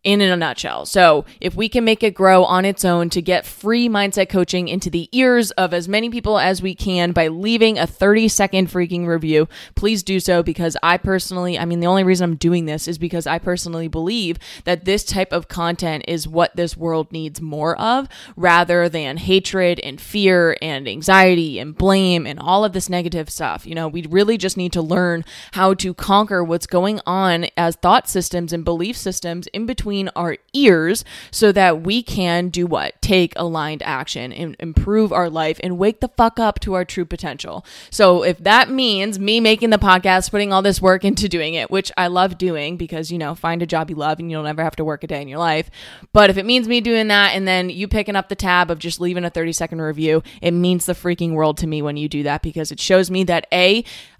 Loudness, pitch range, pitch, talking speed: -17 LUFS, 165-195 Hz, 180 Hz, 225 wpm